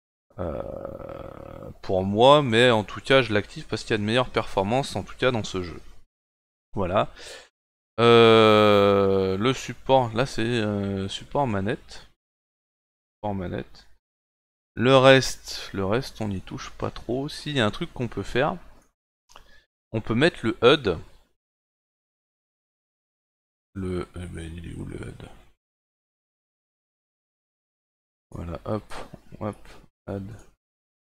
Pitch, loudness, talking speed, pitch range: 105 Hz, -23 LUFS, 125 wpm, 95-125 Hz